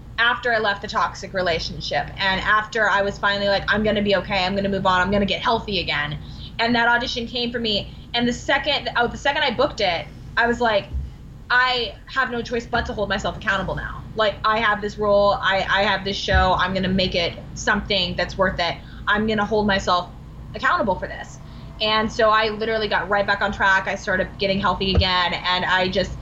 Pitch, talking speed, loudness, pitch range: 200 Hz, 215 wpm, -21 LUFS, 190-225 Hz